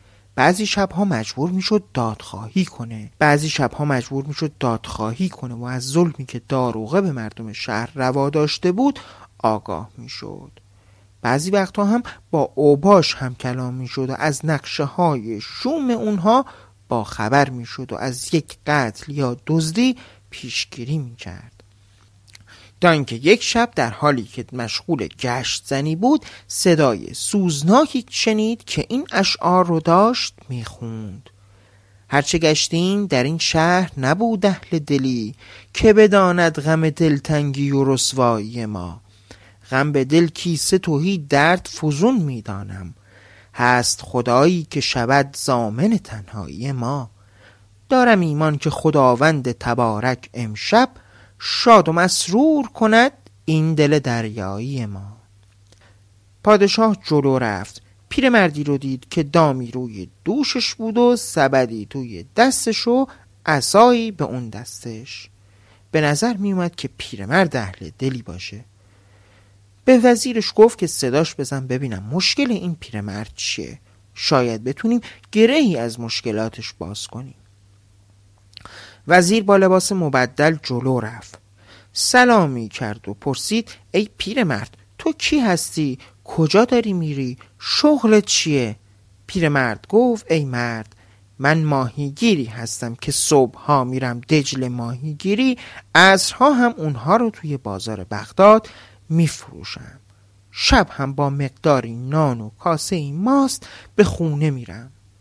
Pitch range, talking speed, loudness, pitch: 110-175 Hz, 125 wpm, -18 LUFS, 135 Hz